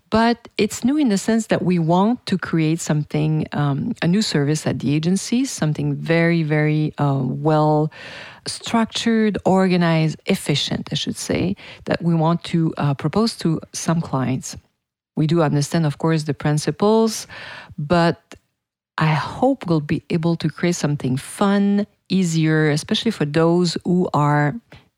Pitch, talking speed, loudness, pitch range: 165 Hz, 150 wpm, -20 LUFS, 150-195 Hz